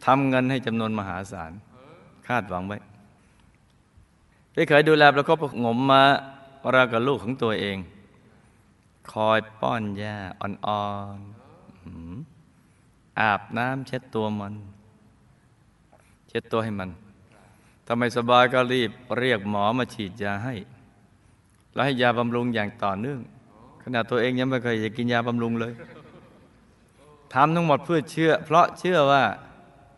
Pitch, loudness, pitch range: 115 Hz, -23 LUFS, 105-130 Hz